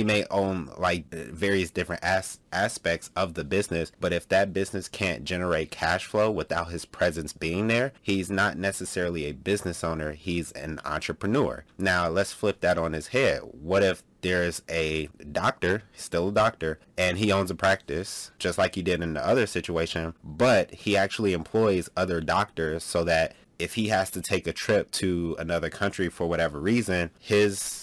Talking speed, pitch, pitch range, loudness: 180 wpm, 90 Hz, 85-100 Hz, -27 LUFS